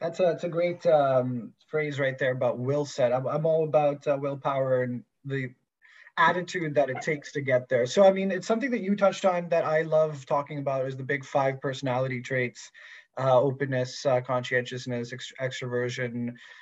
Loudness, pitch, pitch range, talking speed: -27 LUFS, 140 Hz, 125-155 Hz, 190 wpm